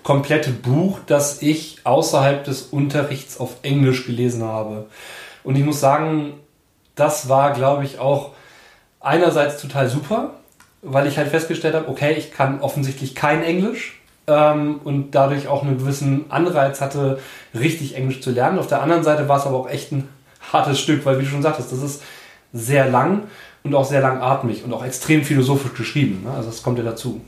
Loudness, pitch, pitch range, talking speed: -19 LUFS, 140 Hz, 135-150 Hz, 180 wpm